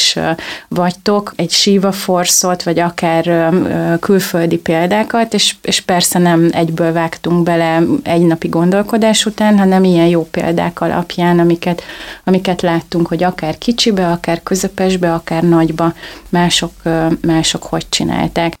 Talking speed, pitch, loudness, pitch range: 125 wpm, 175 Hz, -13 LUFS, 165-185 Hz